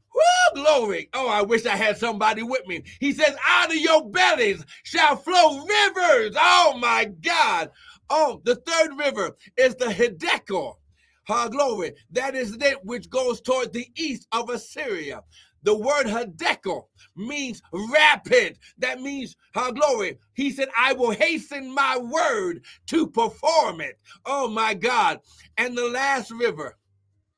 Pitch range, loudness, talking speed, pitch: 230-305 Hz, -22 LUFS, 145 wpm, 260 Hz